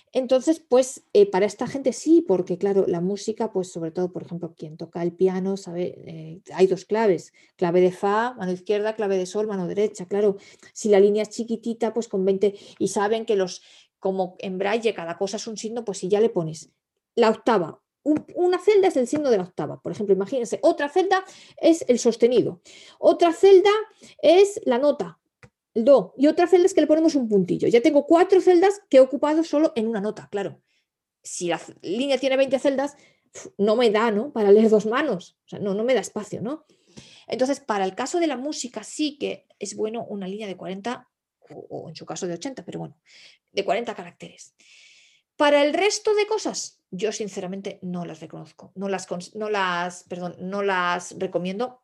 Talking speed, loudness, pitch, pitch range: 200 wpm, -22 LUFS, 215 Hz, 190-275 Hz